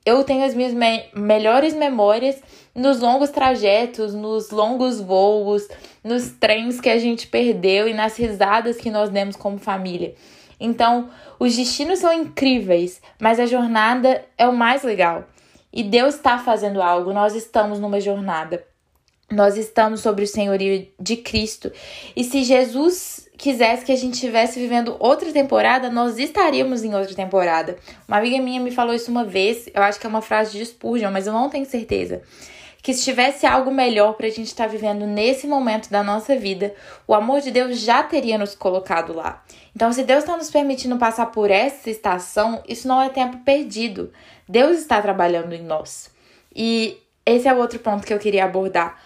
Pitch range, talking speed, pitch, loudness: 205-255 Hz, 180 wpm, 230 Hz, -19 LUFS